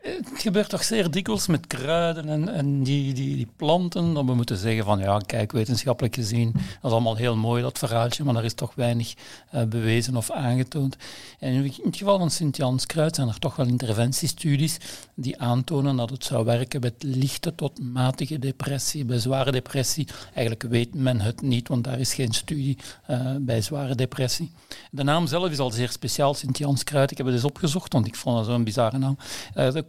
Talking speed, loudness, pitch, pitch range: 200 wpm, -25 LUFS, 130 Hz, 120-150 Hz